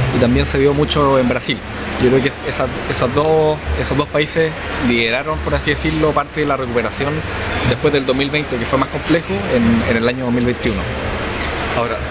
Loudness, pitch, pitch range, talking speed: -17 LUFS, 130 Hz, 120-150 Hz, 170 wpm